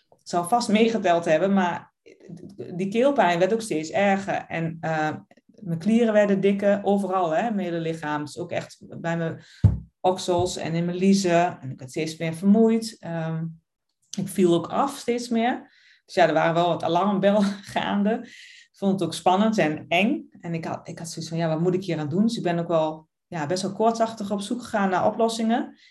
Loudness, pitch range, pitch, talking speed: -24 LUFS, 165-220 Hz, 185 Hz, 205 wpm